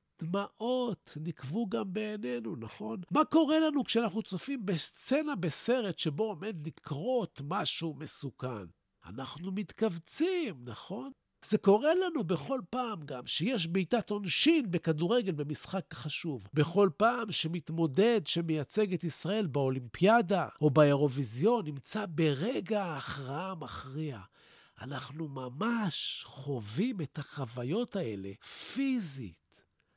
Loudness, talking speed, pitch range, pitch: -32 LUFS, 105 wpm, 145-220 Hz, 175 Hz